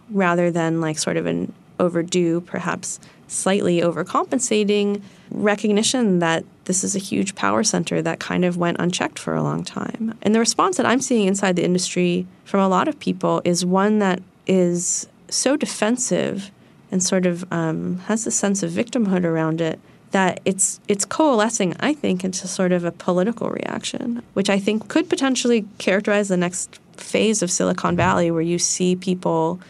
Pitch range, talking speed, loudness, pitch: 175-210 Hz, 175 wpm, -21 LUFS, 190 Hz